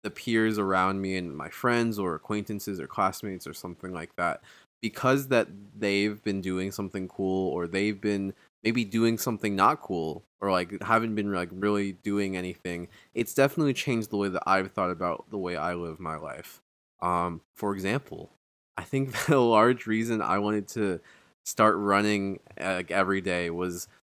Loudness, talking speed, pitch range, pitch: -28 LUFS, 175 wpm, 95-110 Hz, 100 Hz